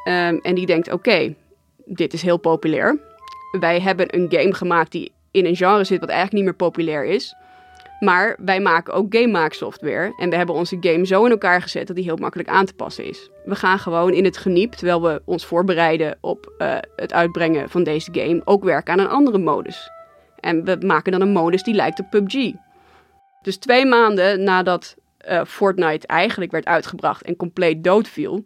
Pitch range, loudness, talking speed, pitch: 170-200 Hz, -18 LUFS, 200 wpm, 185 Hz